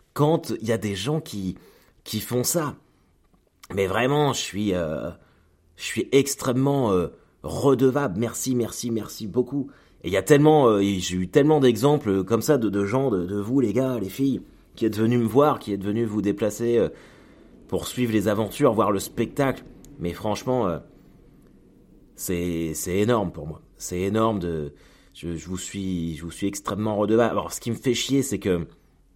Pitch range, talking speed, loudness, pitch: 95-130 Hz, 190 wpm, -24 LUFS, 110 Hz